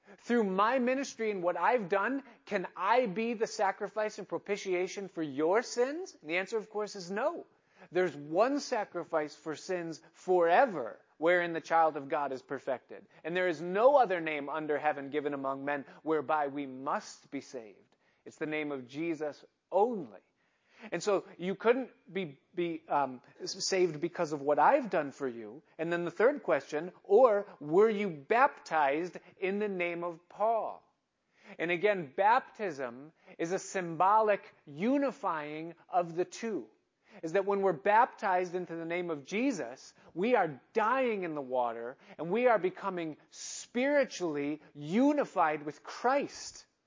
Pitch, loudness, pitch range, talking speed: 180 Hz, -32 LUFS, 155-210 Hz, 155 wpm